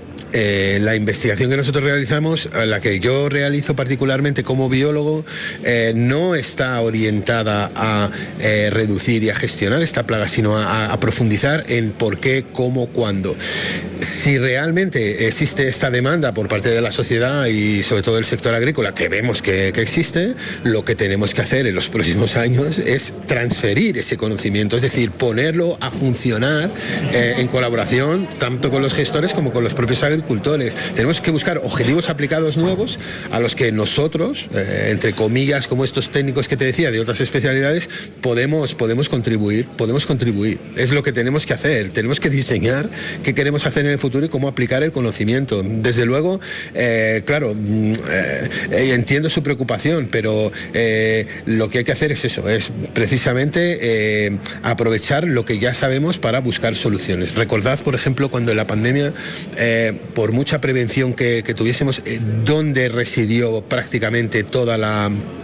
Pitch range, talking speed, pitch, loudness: 110-145 Hz, 165 wpm, 125 Hz, -18 LUFS